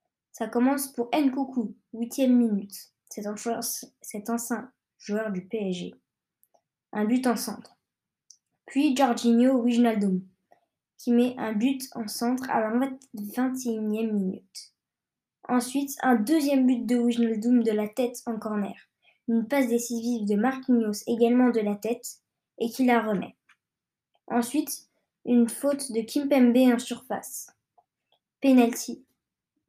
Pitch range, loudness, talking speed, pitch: 220-255 Hz, -26 LUFS, 120 wpm, 240 Hz